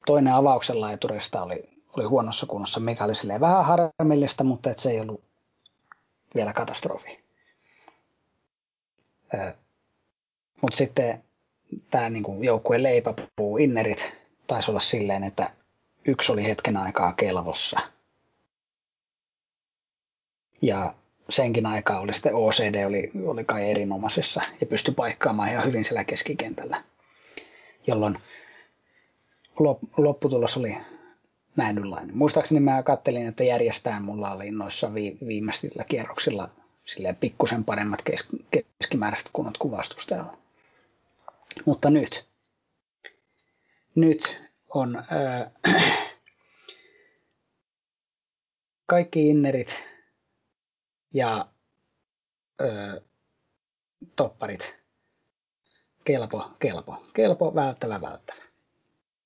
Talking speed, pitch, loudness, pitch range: 85 wpm, 120 Hz, -25 LUFS, 105-150 Hz